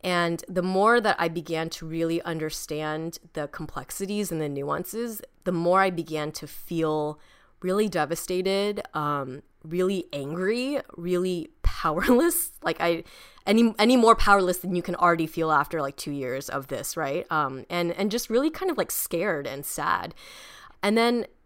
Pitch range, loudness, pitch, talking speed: 160-205 Hz, -26 LUFS, 175 Hz, 160 wpm